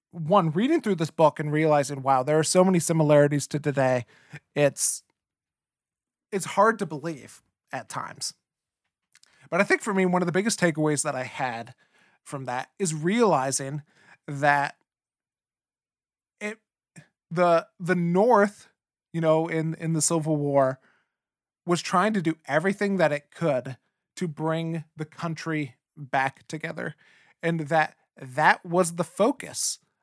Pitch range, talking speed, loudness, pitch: 145-180 Hz, 140 wpm, -25 LUFS, 160 Hz